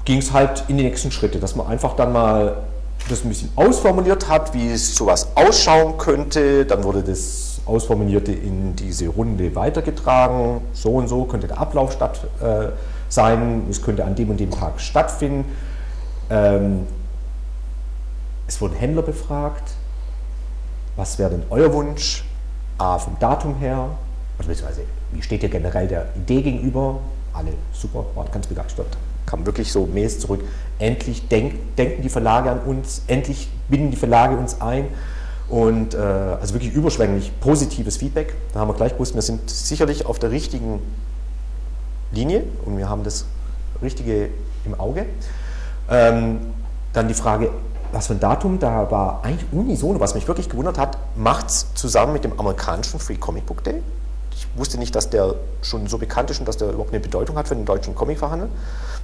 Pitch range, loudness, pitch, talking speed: 80-130 Hz, -21 LUFS, 110 Hz, 170 wpm